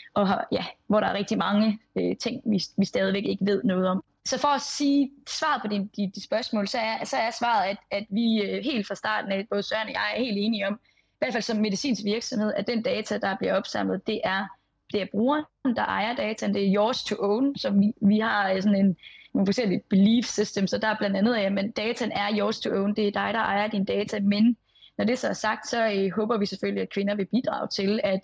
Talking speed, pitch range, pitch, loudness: 250 wpm, 200-230 Hz, 210 Hz, -26 LUFS